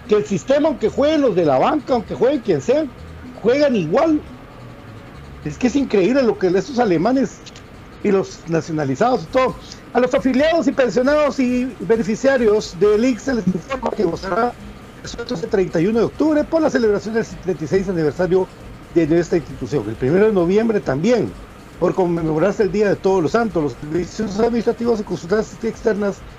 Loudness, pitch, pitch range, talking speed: -18 LUFS, 215 Hz, 175-250 Hz, 175 wpm